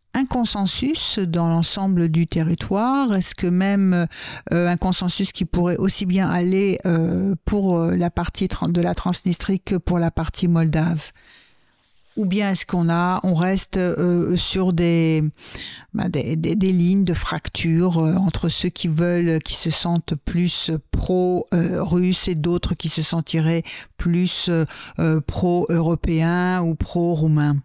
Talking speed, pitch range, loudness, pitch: 145 wpm, 165-185 Hz, -21 LUFS, 175 Hz